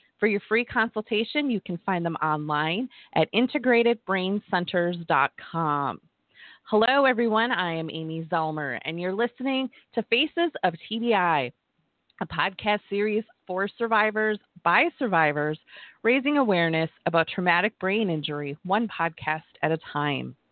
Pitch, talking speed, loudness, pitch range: 195 Hz, 125 wpm, -25 LUFS, 165-230 Hz